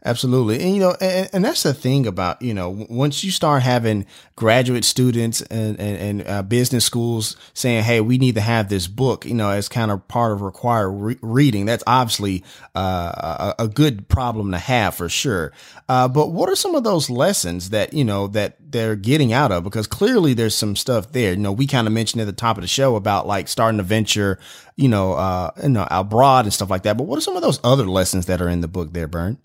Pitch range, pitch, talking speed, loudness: 100-130 Hz, 115 Hz, 240 wpm, -19 LUFS